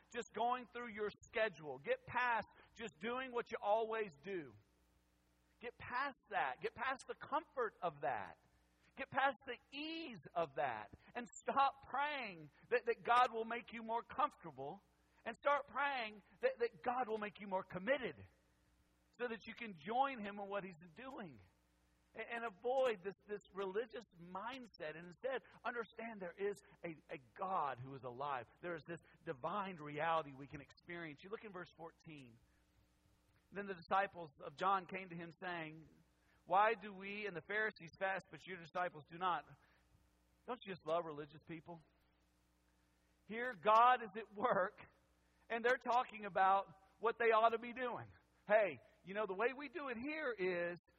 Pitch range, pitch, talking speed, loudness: 160-235 Hz, 195 Hz, 170 wpm, -41 LUFS